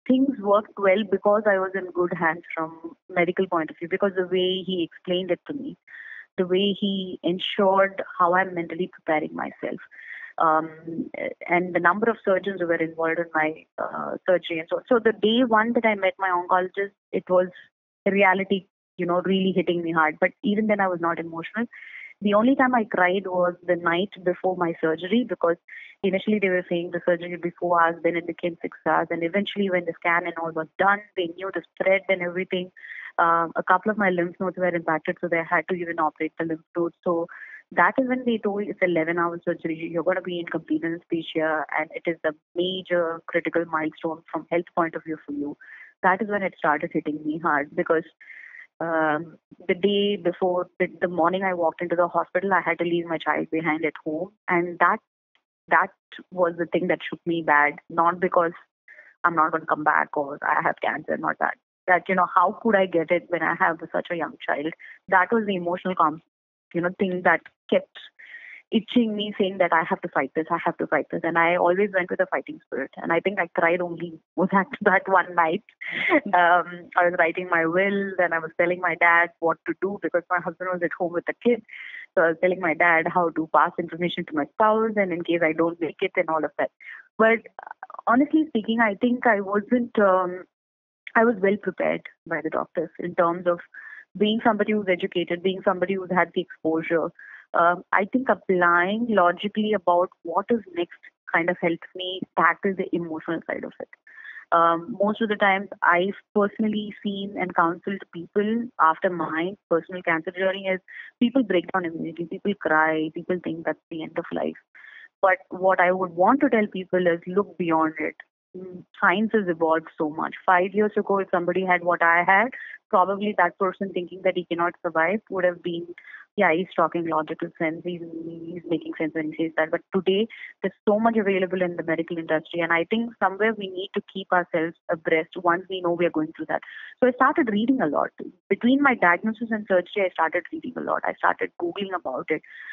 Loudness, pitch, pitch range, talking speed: -24 LUFS, 180 Hz, 170-200 Hz, 210 wpm